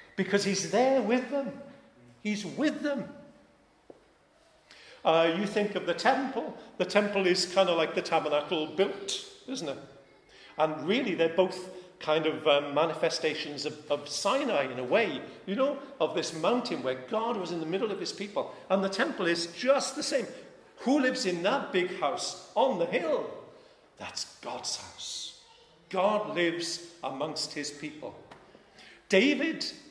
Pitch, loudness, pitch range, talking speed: 190 Hz, -29 LUFS, 165-275 Hz, 155 wpm